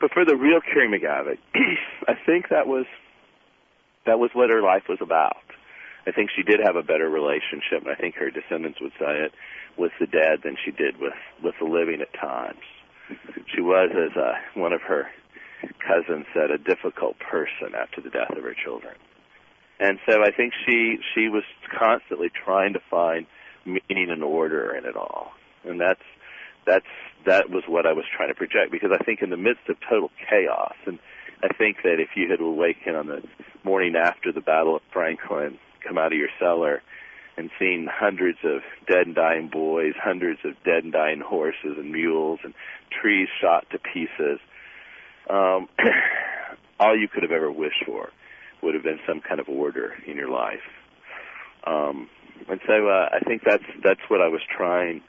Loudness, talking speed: -23 LUFS, 185 wpm